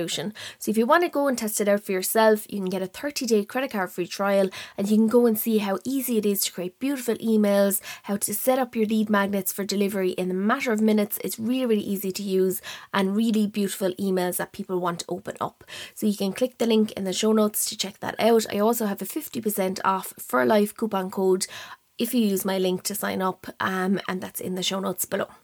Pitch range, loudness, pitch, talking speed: 190-225 Hz, -24 LUFS, 205 Hz, 250 wpm